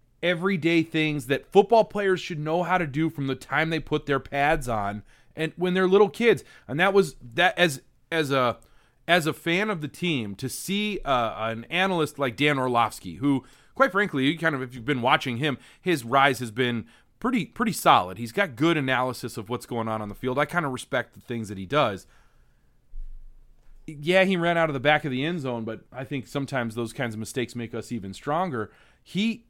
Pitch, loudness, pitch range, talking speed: 140 Hz, -25 LUFS, 125-170 Hz, 215 wpm